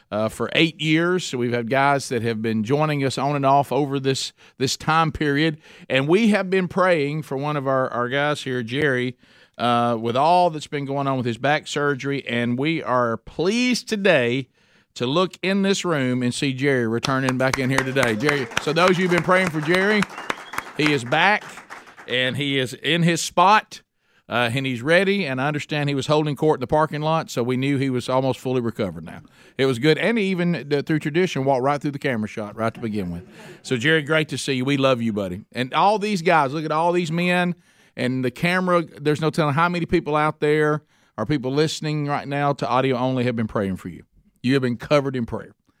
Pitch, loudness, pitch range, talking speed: 140 Hz, -21 LUFS, 125-160 Hz, 225 wpm